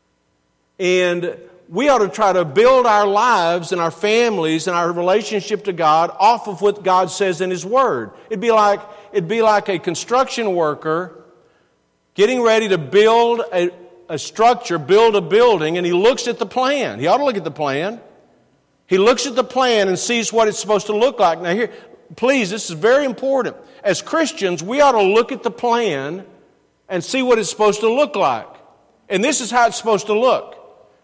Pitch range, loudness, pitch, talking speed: 175-235 Hz, -17 LUFS, 205 Hz, 195 wpm